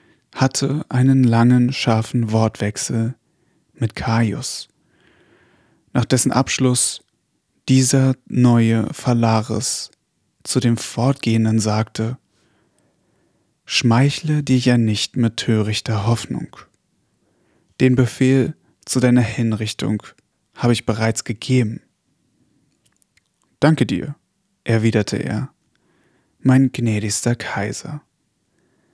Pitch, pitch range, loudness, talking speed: 120 Hz, 110-130 Hz, -18 LUFS, 85 wpm